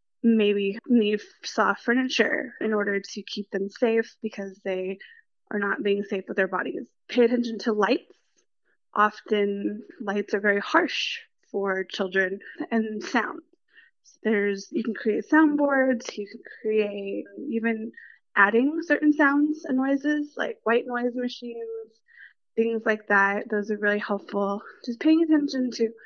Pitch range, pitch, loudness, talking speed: 205-255 Hz, 225 Hz, -25 LUFS, 145 wpm